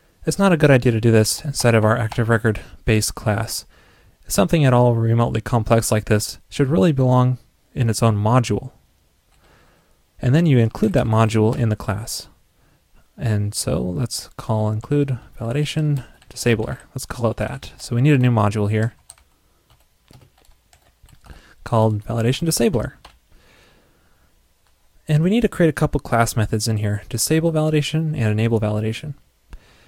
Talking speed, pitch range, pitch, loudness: 150 wpm, 110-135 Hz, 115 Hz, -19 LUFS